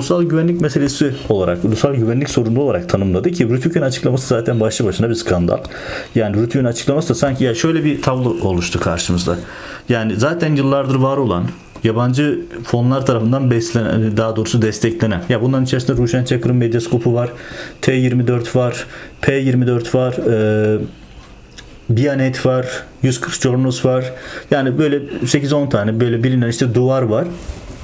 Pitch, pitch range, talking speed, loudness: 125 Hz, 115-135 Hz, 145 wpm, -16 LUFS